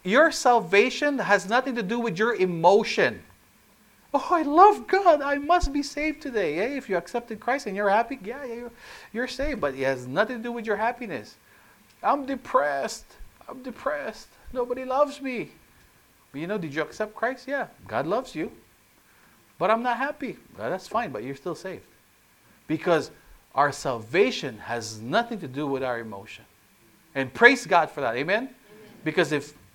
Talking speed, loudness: 175 wpm, -25 LUFS